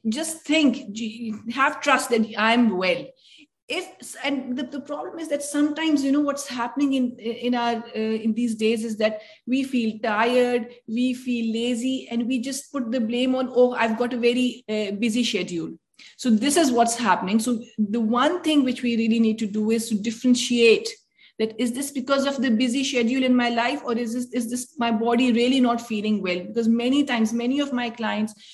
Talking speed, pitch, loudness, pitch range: 200 wpm, 245 Hz, -23 LUFS, 230-265 Hz